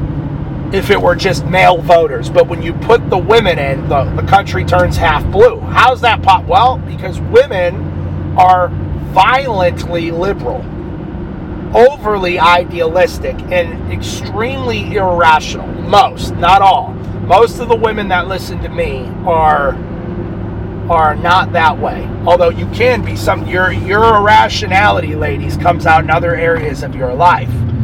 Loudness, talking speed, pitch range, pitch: -12 LUFS, 140 wpm, 145-190 Hz, 170 Hz